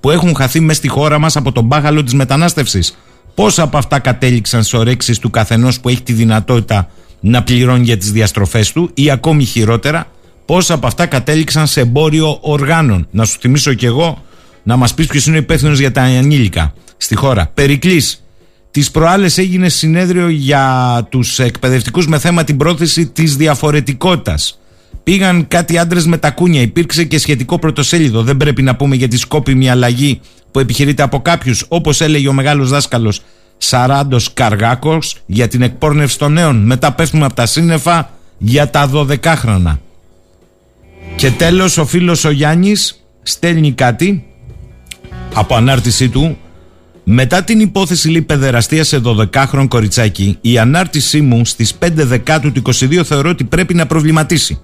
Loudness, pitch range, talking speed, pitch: -11 LUFS, 120-155 Hz, 160 wpm, 140 Hz